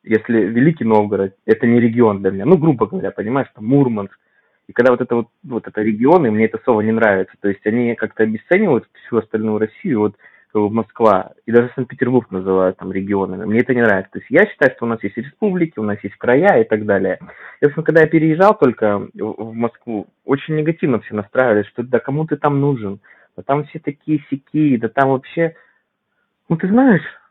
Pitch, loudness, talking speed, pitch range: 115 Hz, -17 LUFS, 200 wpm, 105-140 Hz